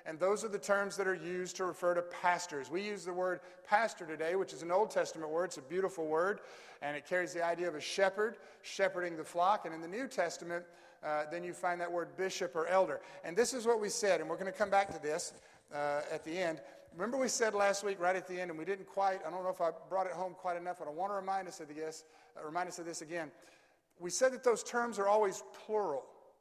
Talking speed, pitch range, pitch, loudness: 265 wpm, 170-200 Hz, 180 Hz, -36 LUFS